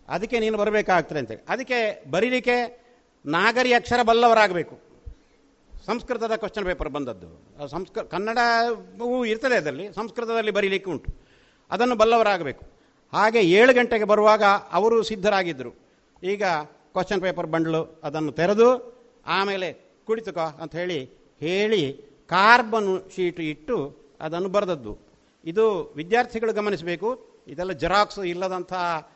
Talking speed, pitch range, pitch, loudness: 105 wpm, 170-230 Hz, 200 Hz, -23 LUFS